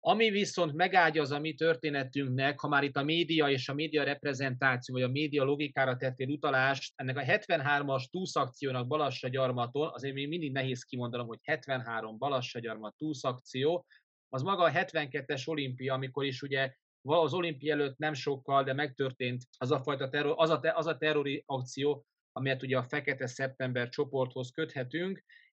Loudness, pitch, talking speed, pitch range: -32 LUFS, 140 Hz, 160 wpm, 130-155 Hz